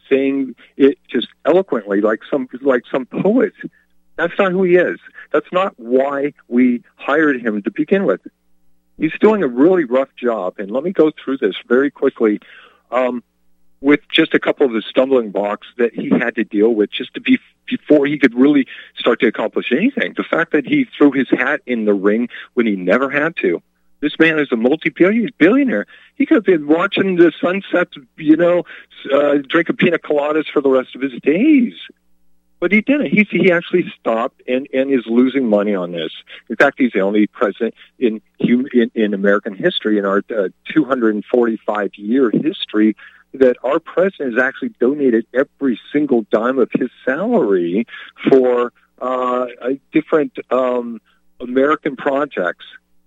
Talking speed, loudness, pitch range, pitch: 175 wpm, -16 LUFS, 115-165 Hz, 135 Hz